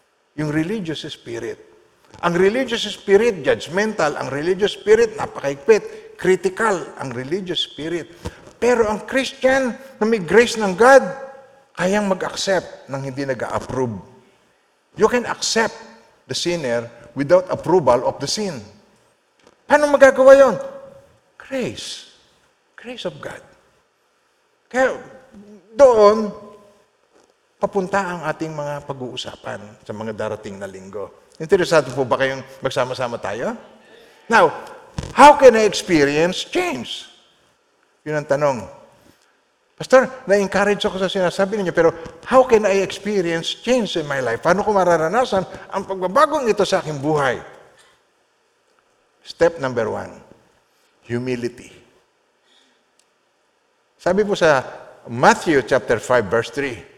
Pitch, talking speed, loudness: 205 Hz, 115 wpm, -18 LUFS